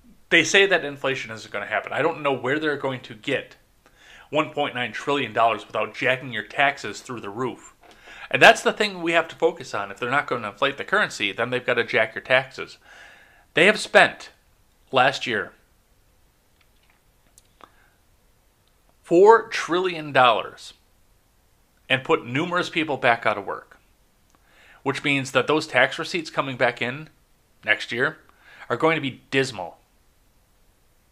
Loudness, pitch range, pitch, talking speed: -22 LUFS, 110-160 Hz, 130 Hz, 155 wpm